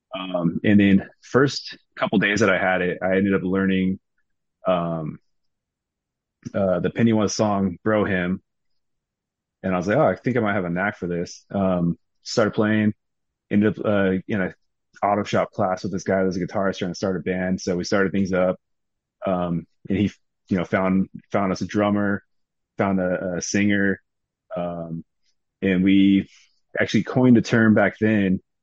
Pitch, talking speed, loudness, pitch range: 95 Hz, 180 wpm, -22 LUFS, 90-105 Hz